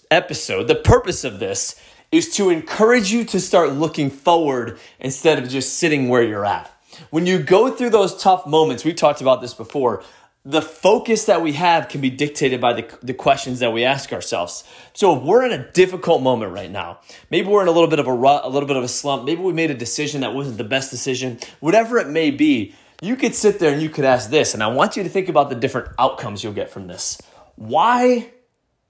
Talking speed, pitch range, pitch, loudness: 230 wpm, 130-190 Hz, 155 Hz, -18 LUFS